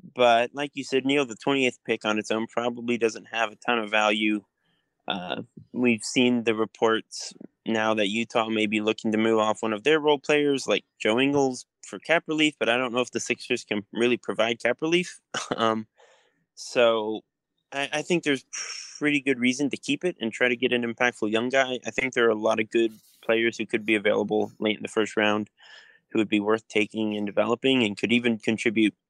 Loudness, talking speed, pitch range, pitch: -25 LUFS, 215 wpm, 110-130 Hz, 115 Hz